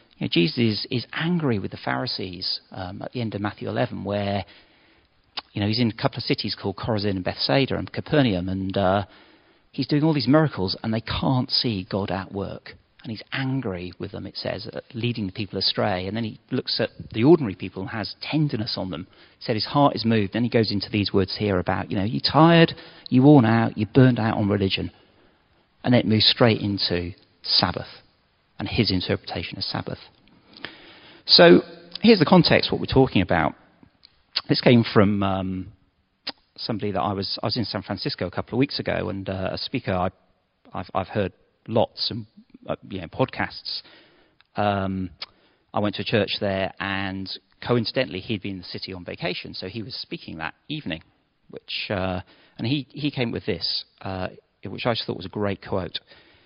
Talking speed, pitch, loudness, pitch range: 200 wpm, 105 Hz, -23 LUFS, 95-120 Hz